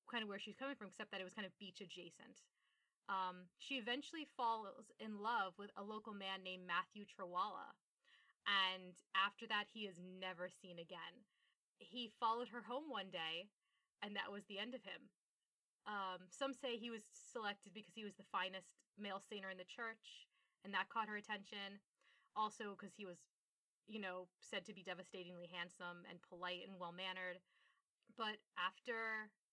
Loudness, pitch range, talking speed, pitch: -48 LUFS, 185-220 Hz, 175 wpm, 200 Hz